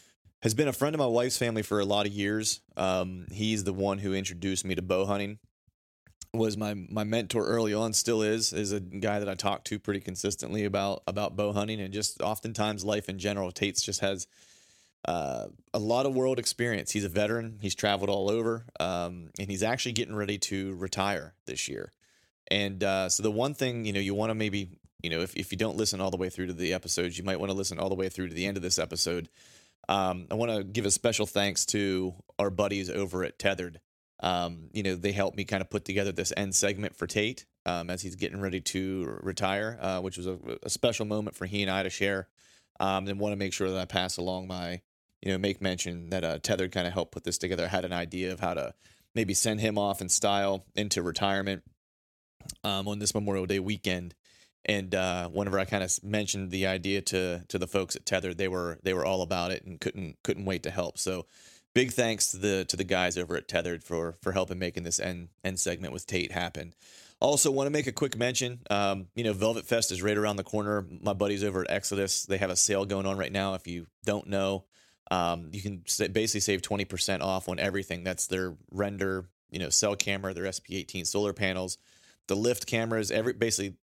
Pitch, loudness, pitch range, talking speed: 100 Hz, -30 LUFS, 95-105 Hz, 230 wpm